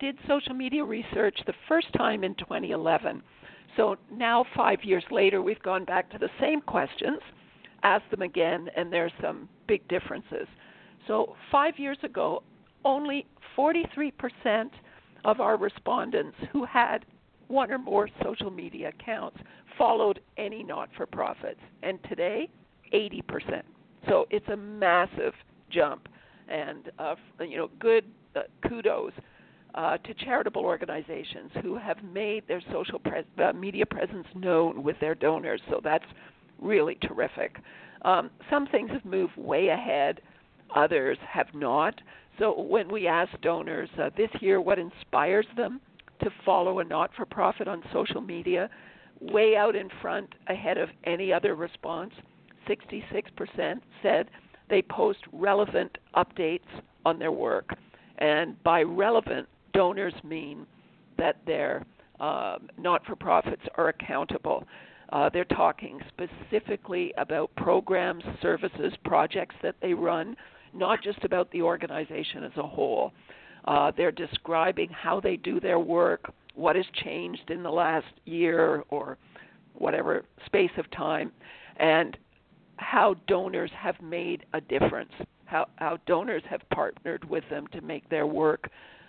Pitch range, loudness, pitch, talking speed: 180-280 Hz, -28 LUFS, 210 Hz, 135 wpm